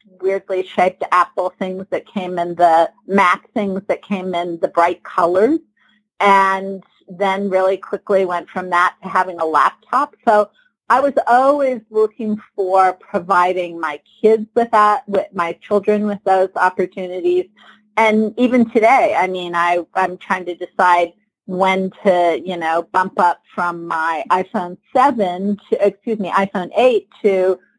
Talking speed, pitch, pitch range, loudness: 150 wpm, 190 Hz, 180-215 Hz, -17 LUFS